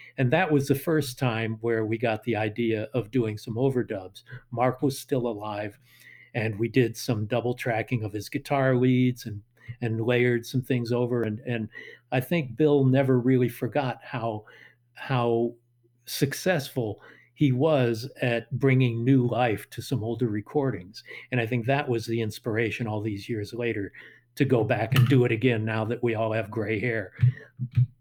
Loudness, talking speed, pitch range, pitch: -26 LUFS, 175 wpm, 115-130 Hz, 120 Hz